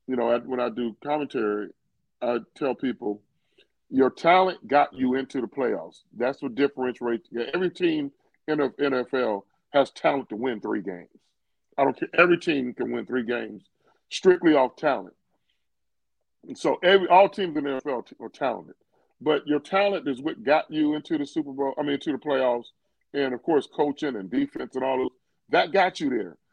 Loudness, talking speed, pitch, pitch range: -25 LUFS, 185 wpm, 140 Hz, 125-185 Hz